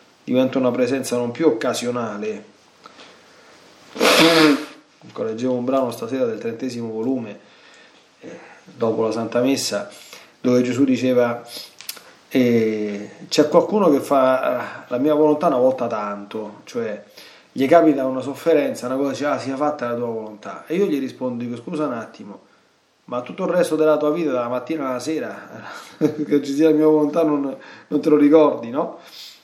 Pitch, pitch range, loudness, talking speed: 130 Hz, 120-150 Hz, -20 LUFS, 160 wpm